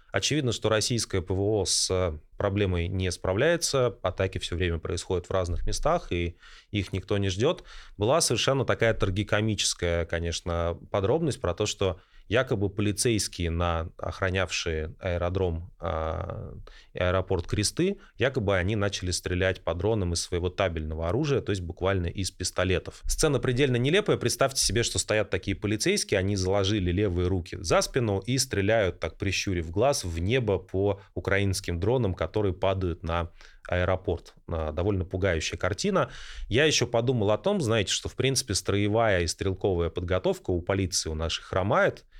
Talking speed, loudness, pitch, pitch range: 145 wpm, -27 LUFS, 95 Hz, 90-110 Hz